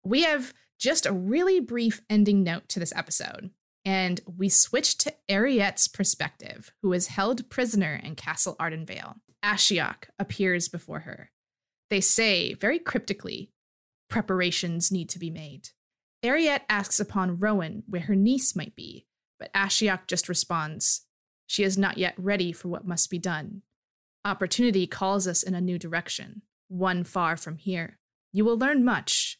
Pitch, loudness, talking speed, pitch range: 195 Hz, -25 LUFS, 155 wpm, 180-215 Hz